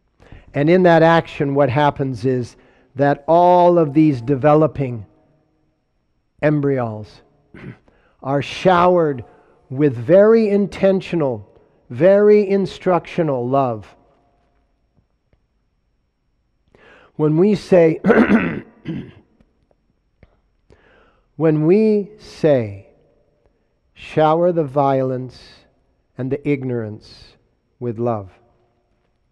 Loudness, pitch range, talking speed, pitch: -16 LUFS, 125-170 Hz, 70 wpm, 145 Hz